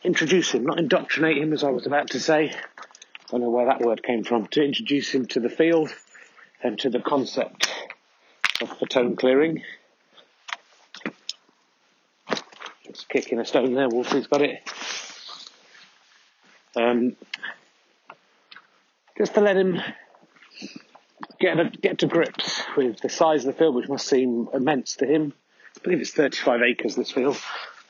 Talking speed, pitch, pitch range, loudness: 150 wpm, 140 Hz, 120-160 Hz, -23 LUFS